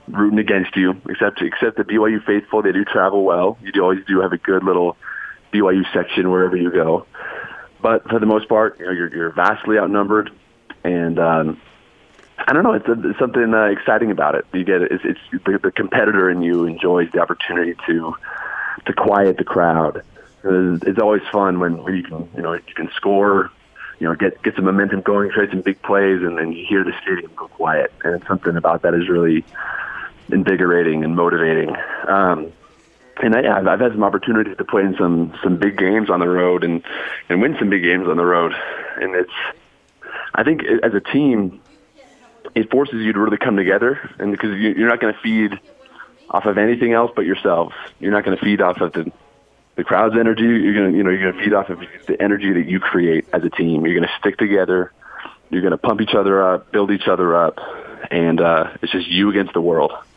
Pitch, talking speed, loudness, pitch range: 95 Hz, 215 wpm, -17 LUFS, 85-105 Hz